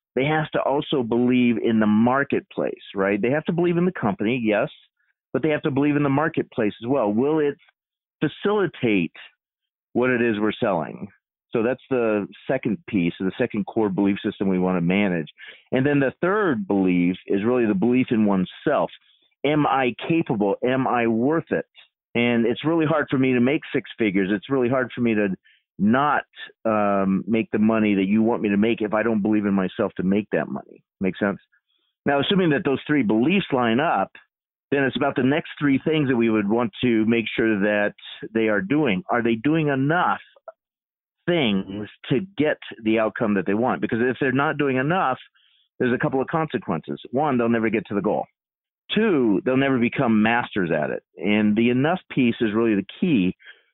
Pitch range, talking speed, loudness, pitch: 105-140 Hz, 200 wpm, -22 LUFS, 120 Hz